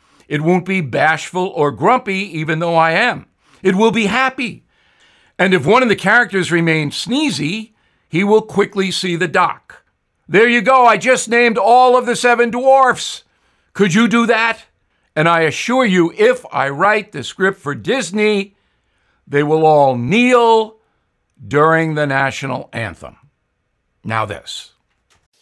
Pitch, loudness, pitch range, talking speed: 190 Hz, -14 LUFS, 150-235 Hz, 150 wpm